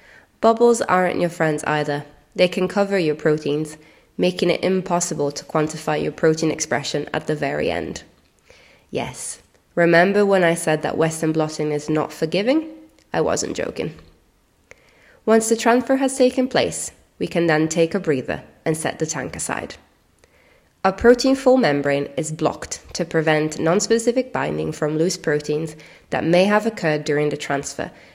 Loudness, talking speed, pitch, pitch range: -20 LUFS, 155 wpm, 160 Hz, 150-190 Hz